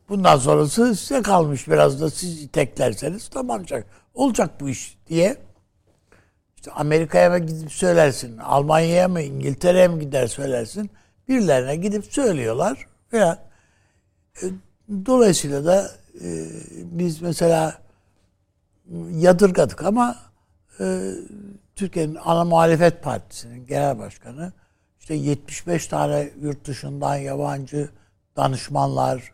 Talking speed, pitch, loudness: 100 wpm, 145 Hz, -21 LUFS